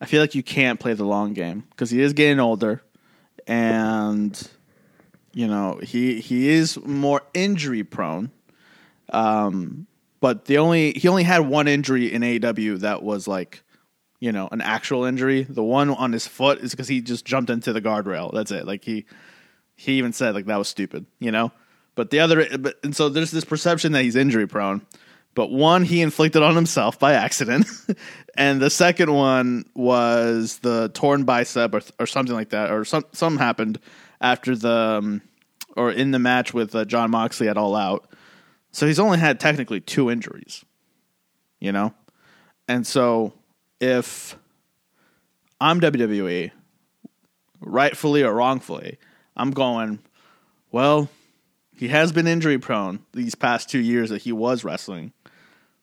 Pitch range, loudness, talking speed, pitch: 115-145 Hz, -21 LUFS, 165 wpm, 125 Hz